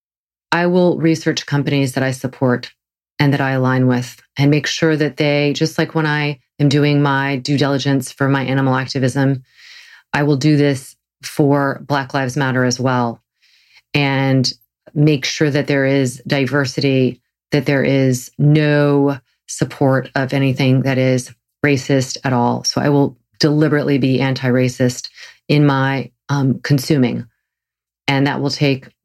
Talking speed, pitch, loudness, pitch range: 155 wpm, 135 Hz, -16 LUFS, 130-145 Hz